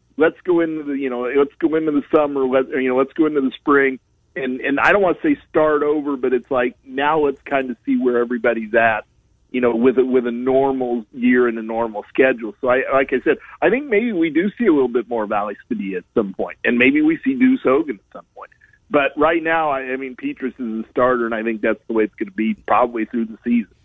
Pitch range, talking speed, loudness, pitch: 120-150 Hz, 260 wpm, -19 LUFS, 130 Hz